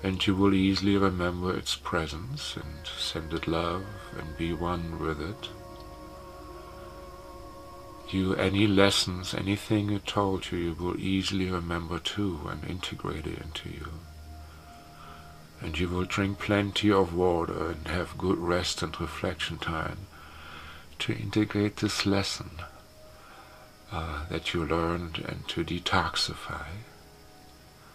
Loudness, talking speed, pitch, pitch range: -29 LUFS, 125 wpm, 90 Hz, 80-95 Hz